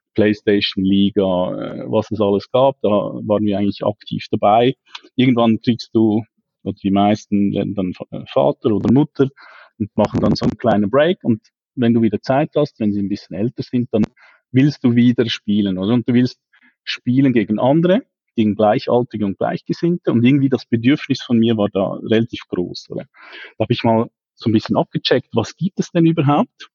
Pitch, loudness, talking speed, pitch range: 115 Hz, -17 LUFS, 180 wpm, 105-130 Hz